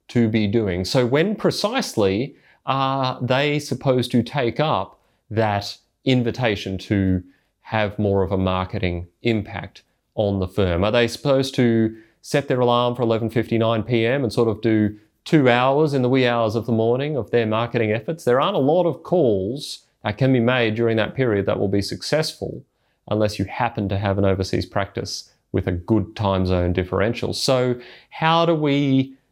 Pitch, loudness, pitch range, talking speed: 115 Hz, -21 LUFS, 100-130 Hz, 175 wpm